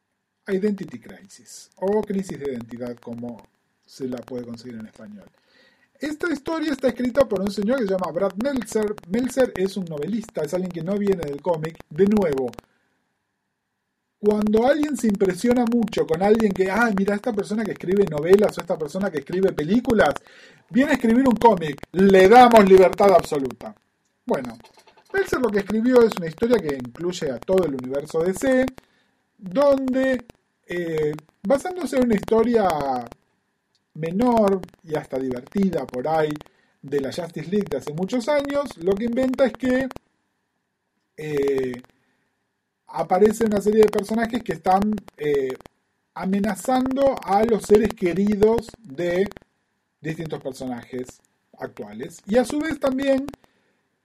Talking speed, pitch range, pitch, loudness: 145 wpm, 165-240 Hz, 200 Hz, -21 LUFS